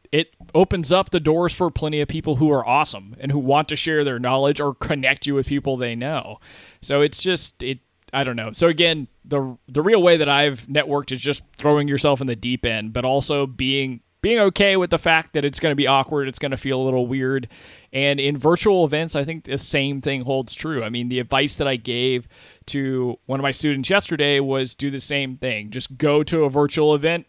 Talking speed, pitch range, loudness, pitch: 235 wpm, 130-150 Hz, -20 LUFS, 140 Hz